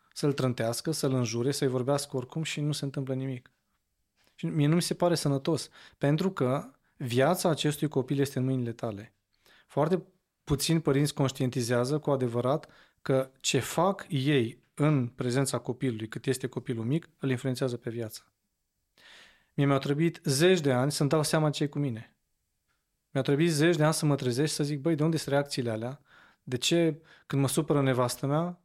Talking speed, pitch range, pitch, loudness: 175 wpm, 130-155 Hz, 140 Hz, -29 LUFS